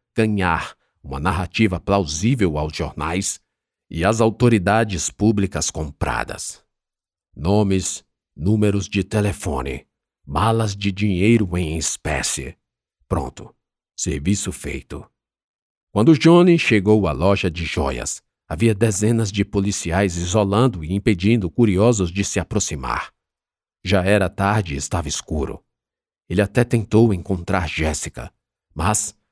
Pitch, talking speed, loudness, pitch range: 100 Hz, 110 wpm, -20 LUFS, 85-110 Hz